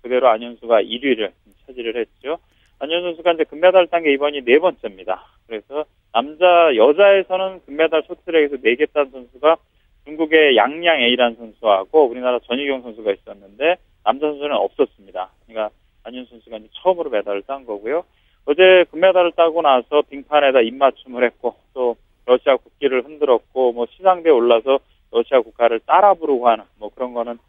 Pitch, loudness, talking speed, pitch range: 145 Hz, -17 LUFS, 385 characters per minute, 120-170 Hz